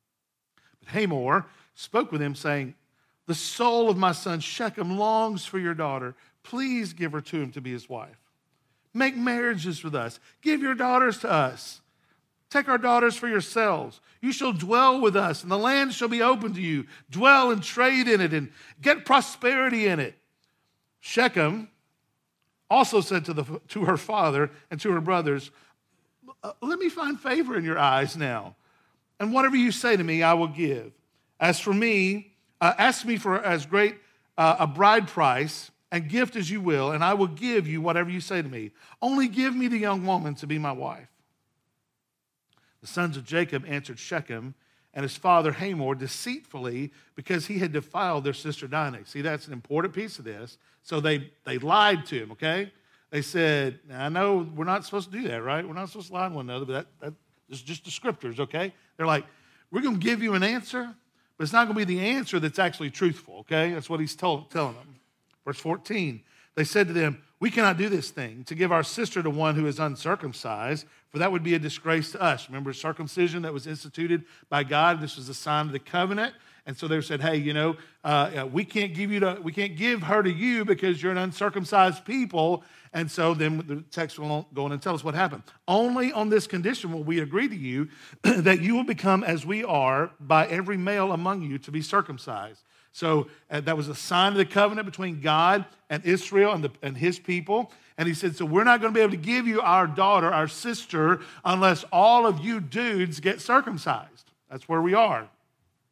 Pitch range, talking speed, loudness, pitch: 150-205 Hz, 205 wpm, -25 LUFS, 175 Hz